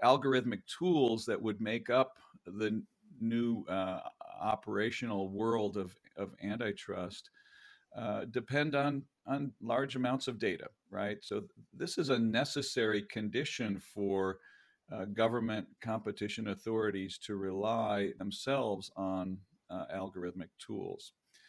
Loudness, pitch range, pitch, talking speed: -36 LUFS, 100-135 Hz, 115 Hz, 115 wpm